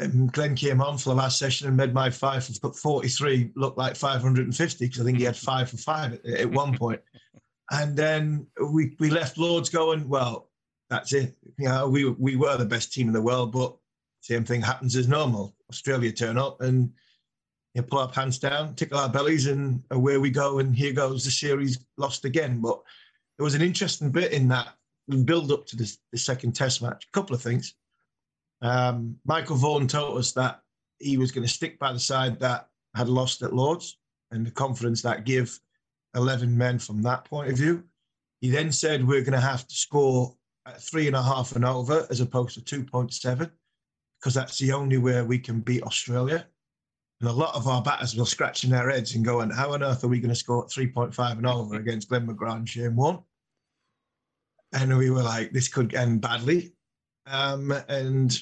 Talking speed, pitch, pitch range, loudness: 210 wpm, 130 Hz, 125-140 Hz, -26 LUFS